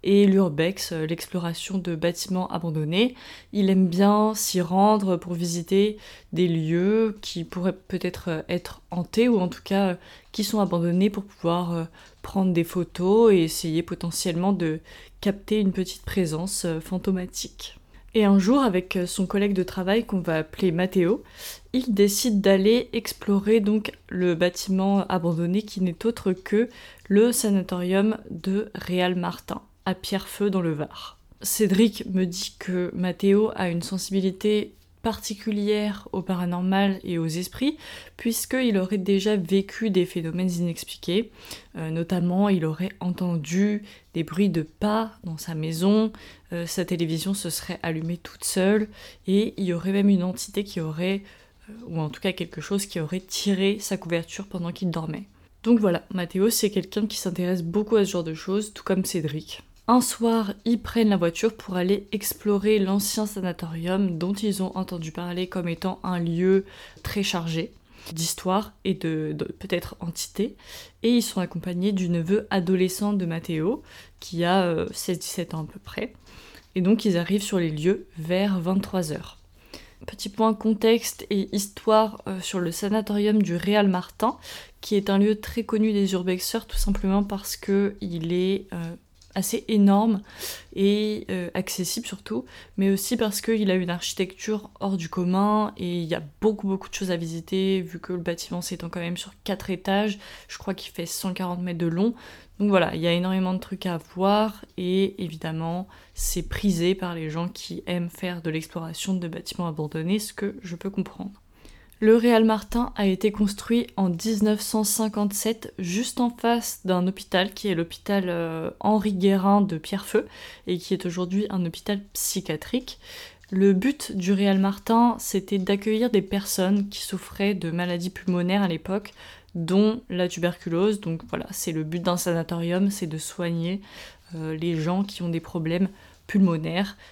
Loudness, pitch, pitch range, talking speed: -25 LUFS, 190 Hz, 175-205 Hz, 165 wpm